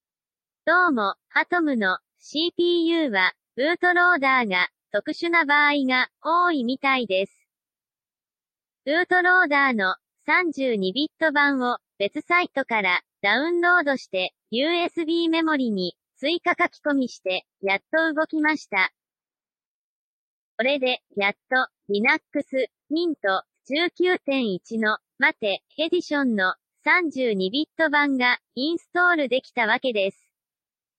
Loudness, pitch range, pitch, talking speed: -22 LUFS, 225-330 Hz, 285 Hz, 245 characters per minute